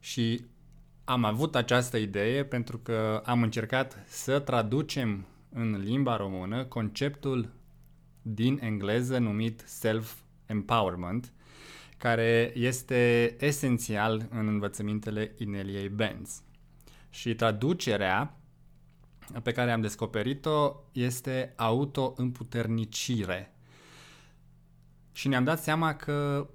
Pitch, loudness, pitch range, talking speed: 115 Hz, -30 LUFS, 110-130 Hz, 90 wpm